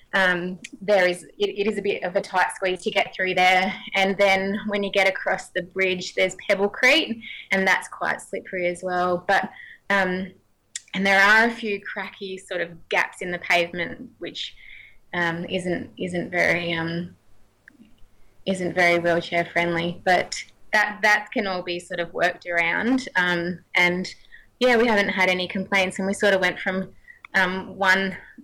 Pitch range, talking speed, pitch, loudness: 180-200 Hz, 175 wpm, 190 Hz, -22 LUFS